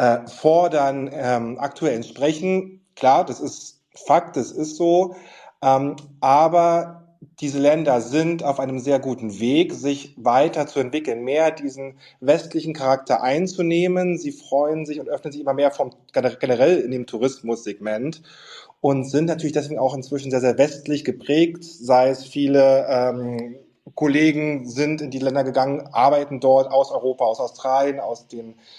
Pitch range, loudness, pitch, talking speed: 130-155 Hz, -21 LUFS, 140 Hz, 150 wpm